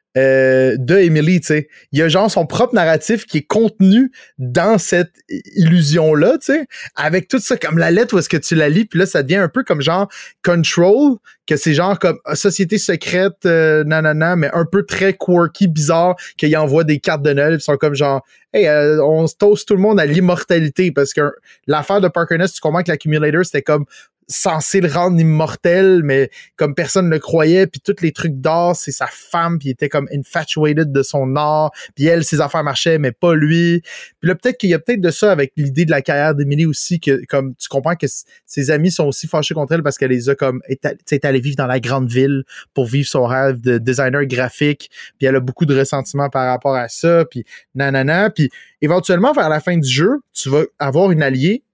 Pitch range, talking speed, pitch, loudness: 145-180 Hz, 225 wpm, 160 Hz, -15 LUFS